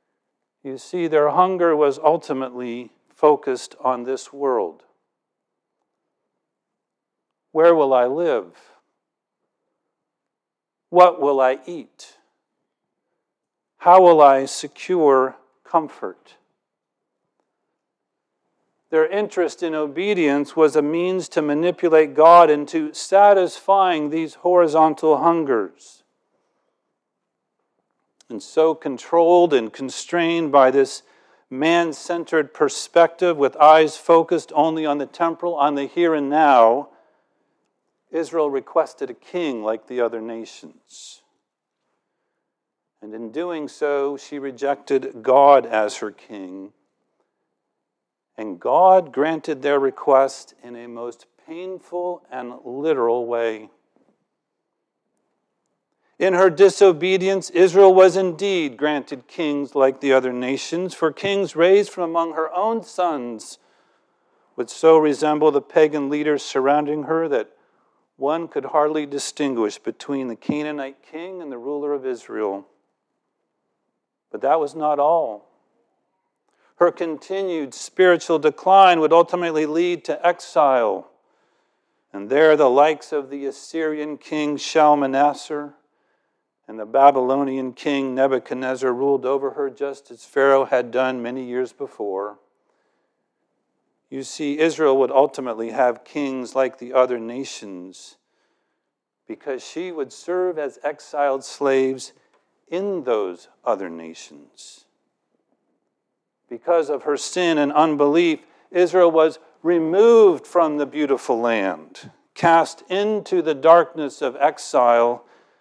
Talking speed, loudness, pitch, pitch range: 110 wpm, -19 LUFS, 150 Hz, 135-170 Hz